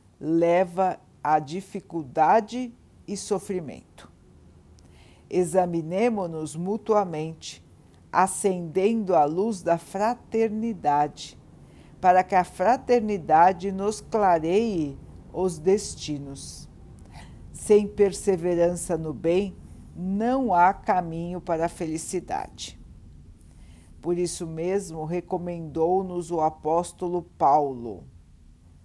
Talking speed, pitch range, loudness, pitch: 75 wpm, 155-195 Hz, -25 LUFS, 175 Hz